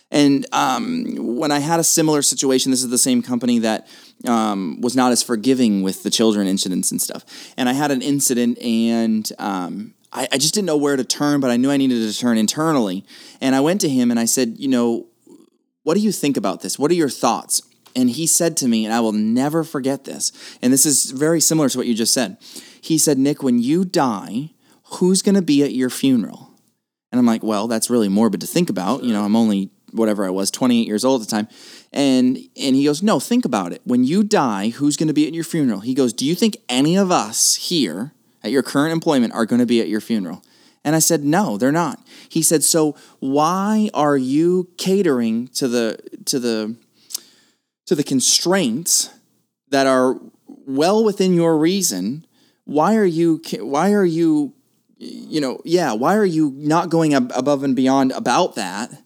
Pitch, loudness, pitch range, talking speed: 140 Hz, -18 LUFS, 120-175 Hz, 210 wpm